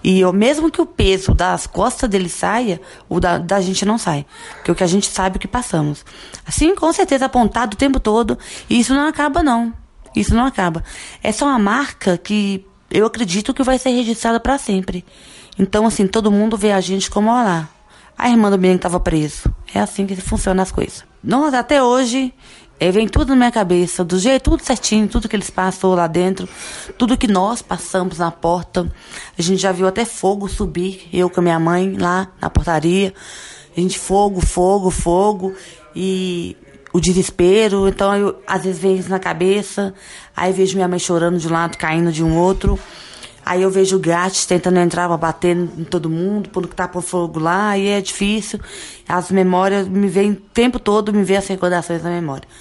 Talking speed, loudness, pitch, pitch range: 200 wpm, -17 LUFS, 190 Hz, 180-215 Hz